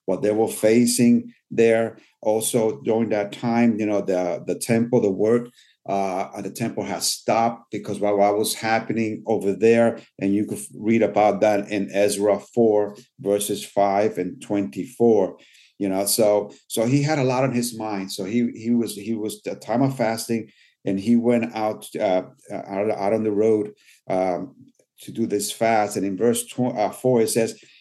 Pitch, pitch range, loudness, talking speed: 110 Hz, 100-115 Hz, -22 LUFS, 180 wpm